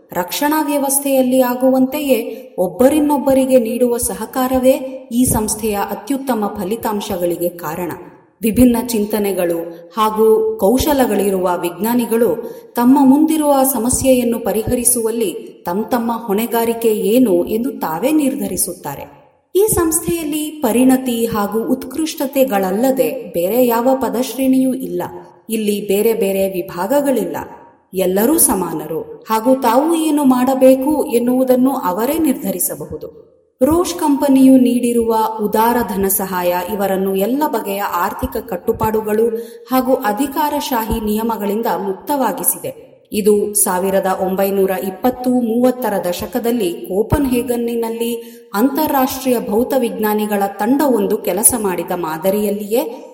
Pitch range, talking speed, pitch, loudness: 210-265 Hz, 90 wpm, 235 Hz, -16 LUFS